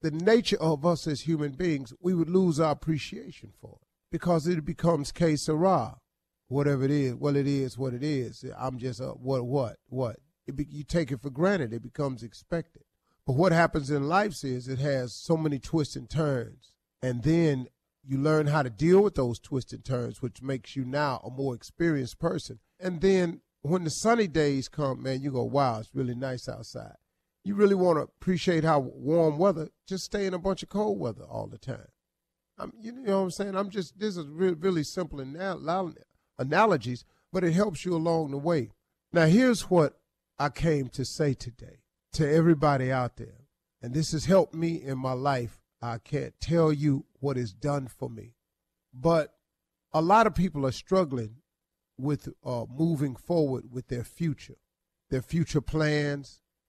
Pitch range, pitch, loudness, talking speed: 130-170 Hz, 150 Hz, -28 LUFS, 185 wpm